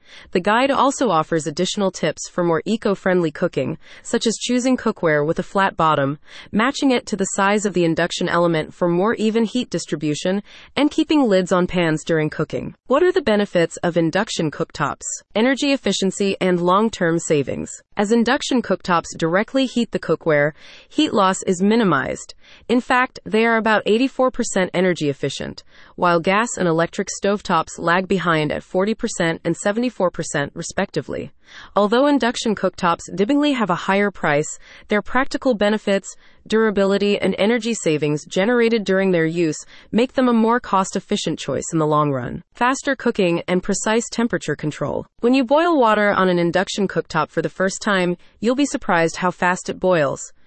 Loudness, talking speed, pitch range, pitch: -19 LUFS, 165 wpm, 170-230 Hz, 195 Hz